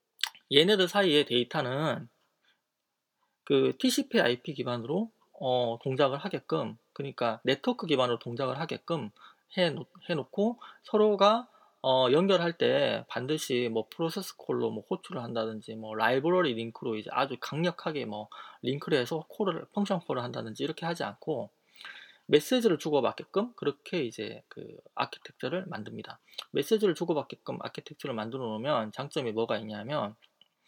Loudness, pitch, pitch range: -30 LUFS, 155 Hz, 120-200 Hz